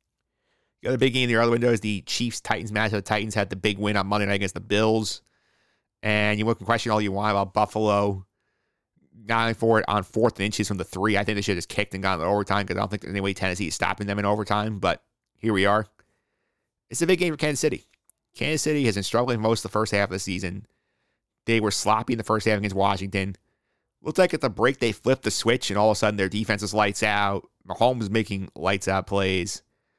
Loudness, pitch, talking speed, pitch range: -24 LUFS, 105 Hz, 250 wpm, 100-115 Hz